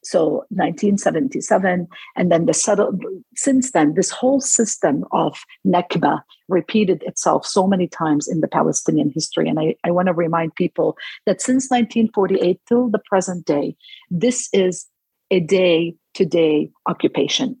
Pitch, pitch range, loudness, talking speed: 190 Hz, 170-240 Hz, -19 LUFS, 145 wpm